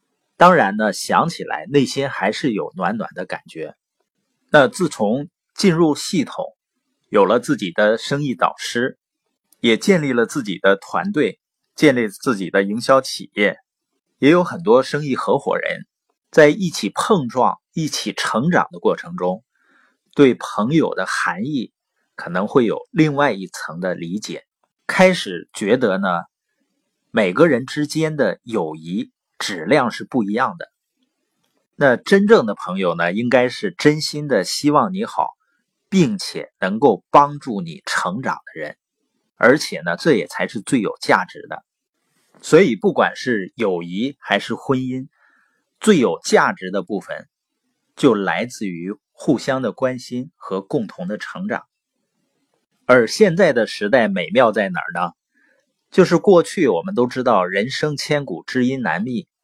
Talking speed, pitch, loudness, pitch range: 215 characters per minute, 145 Hz, -18 LUFS, 120-180 Hz